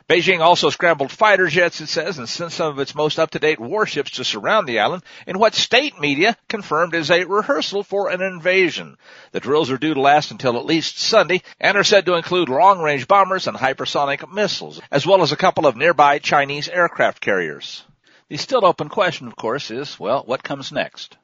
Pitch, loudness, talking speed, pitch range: 170 Hz, -18 LUFS, 200 wpm, 145-190 Hz